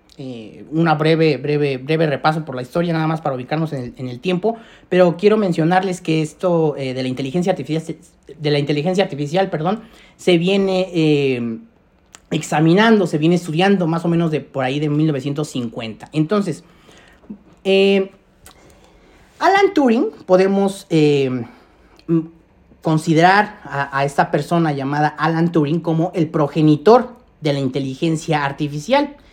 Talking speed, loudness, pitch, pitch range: 140 wpm, -18 LUFS, 160 Hz, 145-185 Hz